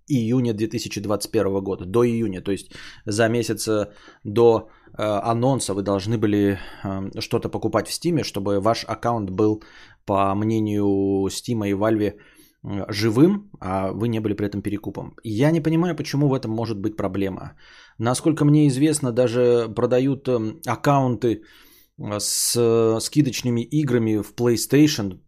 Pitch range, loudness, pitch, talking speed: 105-125 Hz, -22 LUFS, 110 Hz, 130 wpm